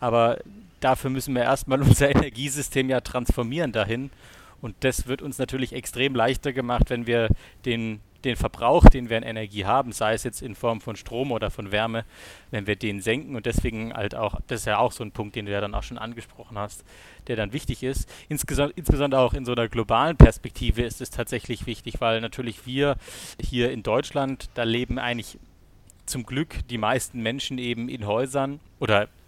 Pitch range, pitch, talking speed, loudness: 110-130 Hz, 120 Hz, 195 wpm, -25 LUFS